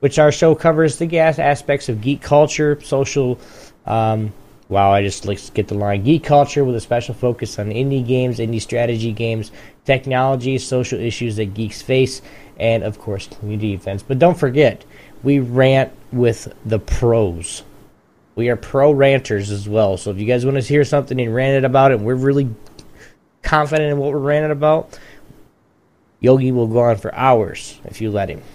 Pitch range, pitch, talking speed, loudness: 110-140 Hz, 125 Hz, 185 wpm, -17 LUFS